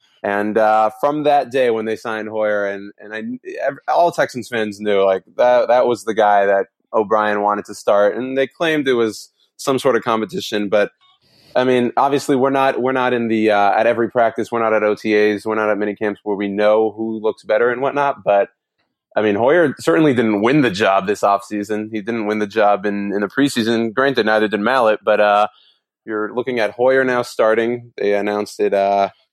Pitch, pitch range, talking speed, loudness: 110 Hz, 105-120 Hz, 210 wpm, -17 LUFS